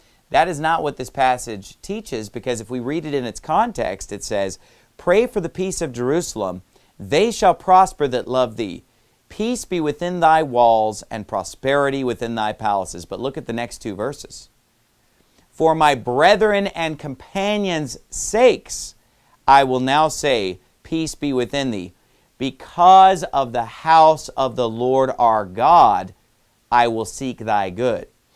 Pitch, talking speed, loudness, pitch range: 130 Hz, 155 wpm, -19 LUFS, 115-160 Hz